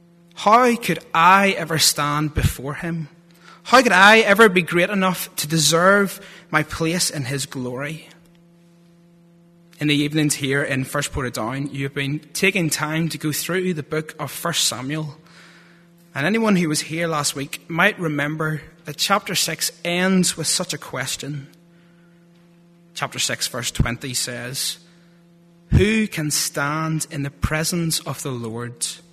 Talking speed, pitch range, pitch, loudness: 150 wpm, 145-175 Hz, 165 Hz, -19 LUFS